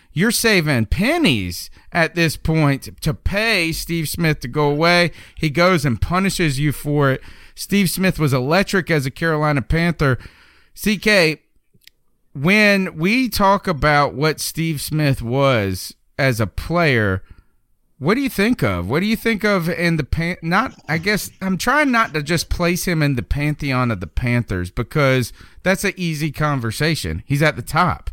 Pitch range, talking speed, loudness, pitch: 130-180 Hz, 165 wpm, -18 LUFS, 155 Hz